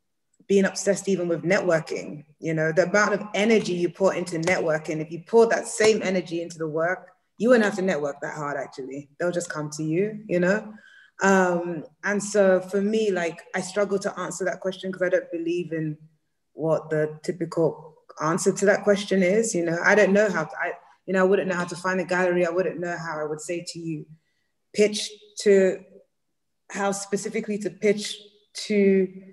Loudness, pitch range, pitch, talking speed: -24 LUFS, 165-200 Hz, 185 Hz, 205 wpm